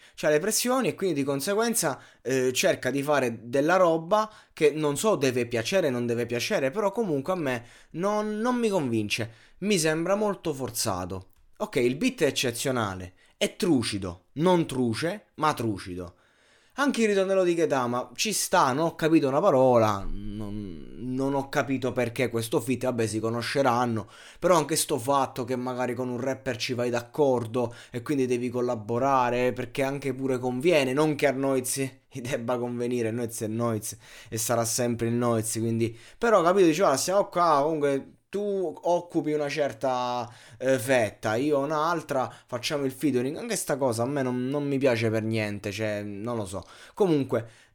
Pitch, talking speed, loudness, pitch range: 130 Hz, 170 wpm, -26 LUFS, 115-150 Hz